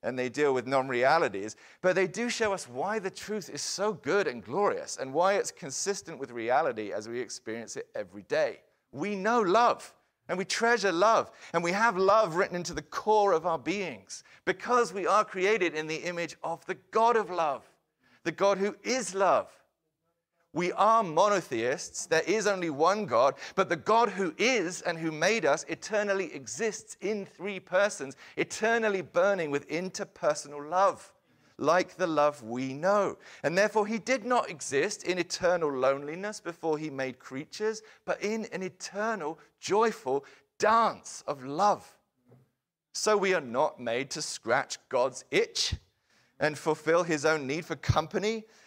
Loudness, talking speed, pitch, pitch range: -29 LUFS, 165 wpm, 185 Hz, 155-215 Hz